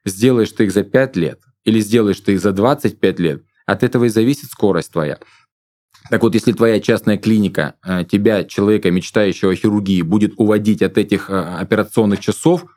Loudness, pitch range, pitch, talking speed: -16 LUFS, 95-115 Hz, 105 Hz, 170 wpm